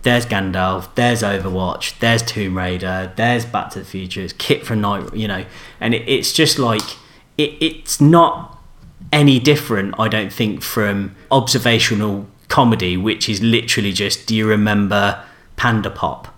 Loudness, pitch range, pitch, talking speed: -17 LUFS, 100-120 Hz, 110 Hz, 155 wpm